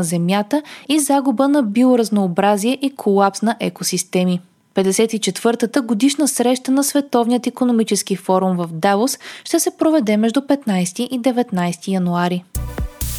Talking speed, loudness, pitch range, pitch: 120 wpm, -18 LUFS, 190-265 Hz, 225 Hz